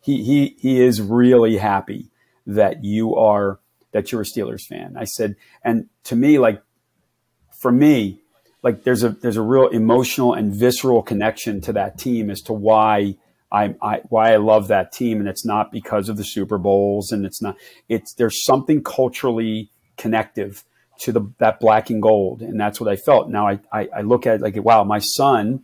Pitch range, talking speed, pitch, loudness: 105-120 Hz, 195 wpm, 110 Hz, -18 LUFS